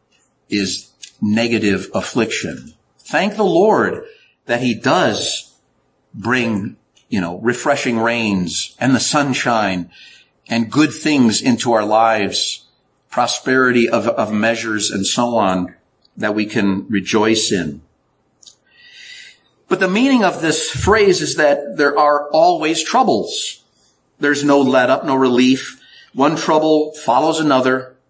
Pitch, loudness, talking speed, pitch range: 130 Hz, -16 LUFS, 120 wpm, 110-155 Hz